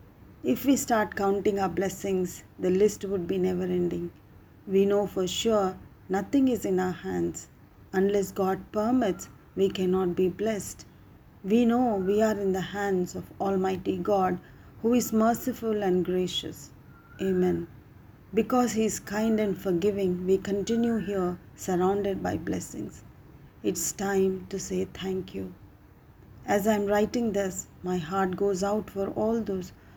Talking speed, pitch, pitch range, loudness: 150 wpm, 195 Hz, 180-210 Hz, -28 LUFS